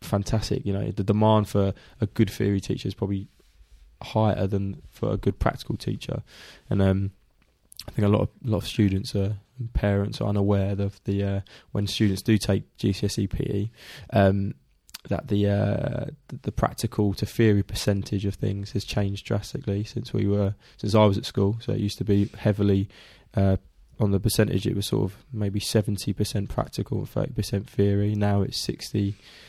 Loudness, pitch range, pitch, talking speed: -26 LUFS, 100-110 Hz, 100 Hz, 185 wpm